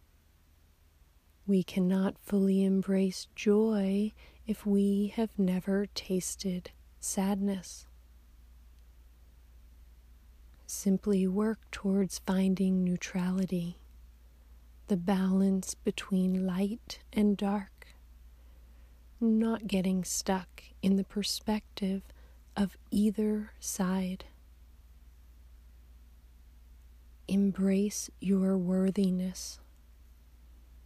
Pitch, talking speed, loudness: 185 Hz, 65 wpm, -31 LUFS